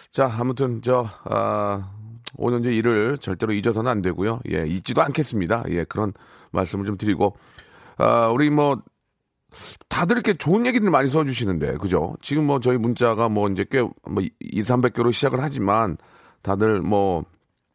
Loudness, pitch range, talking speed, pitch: -22 LUFS, 100-135 Hz, 300 characters per minute, 115 Hz